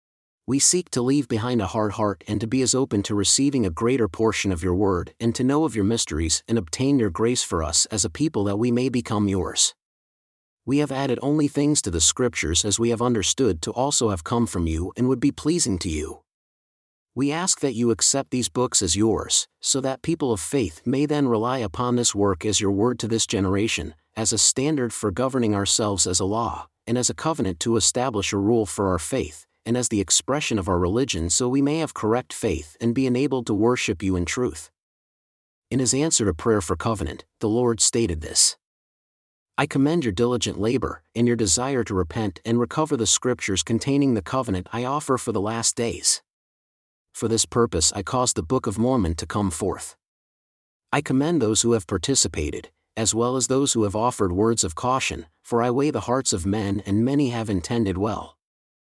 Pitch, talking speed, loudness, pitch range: 115 Hz, 210 wpm, -22 LUFS, 100-130 Hz